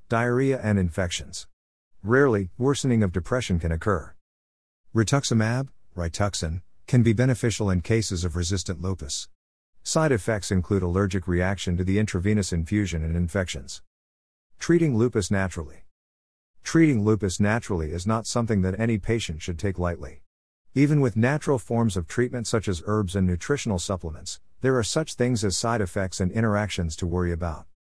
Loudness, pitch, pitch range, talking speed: -25 LUFS, 100 Hz, 85-115 Hz, 150 wpm